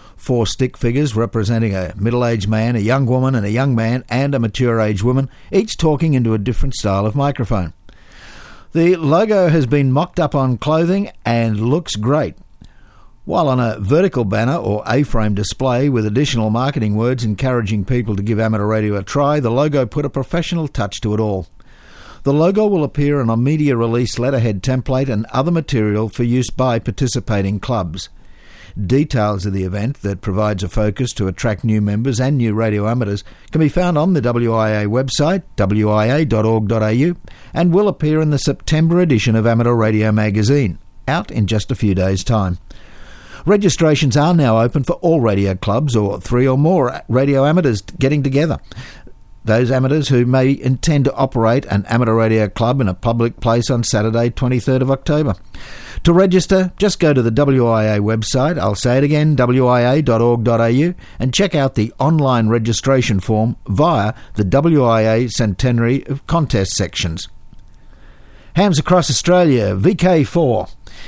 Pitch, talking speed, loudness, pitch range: 120 Hz, 165 wpm, -16 LUFS, 110-140 Hz